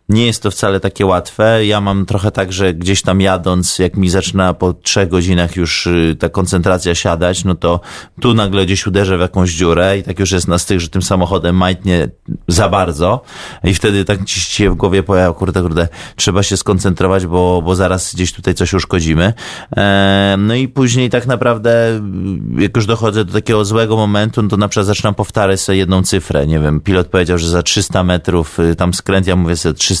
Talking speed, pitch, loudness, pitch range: 200 wpm, 95 Hz, -13 LUFS, 90-105 Hz